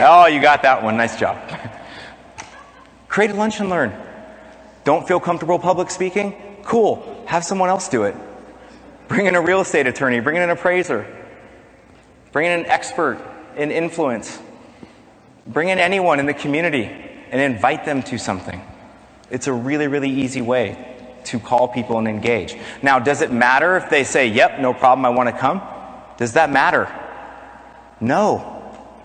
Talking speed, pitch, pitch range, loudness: 165 wpm, 165 Hz, 130-185 Hz, -18 LUFS